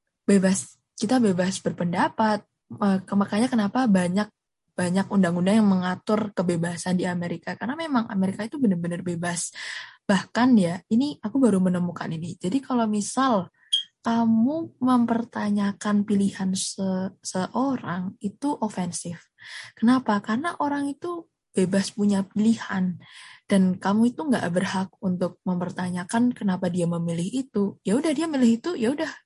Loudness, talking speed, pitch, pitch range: -25 LUFS, 125 wpm, 200 Hz, 185-235 Hz